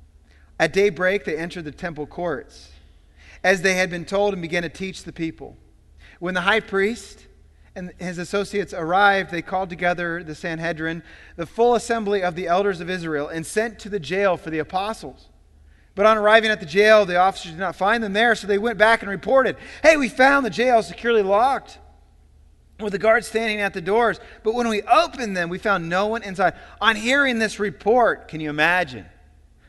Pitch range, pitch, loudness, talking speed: 160-215 Hz, 185 Hz, -21 LUFS, 195 wpm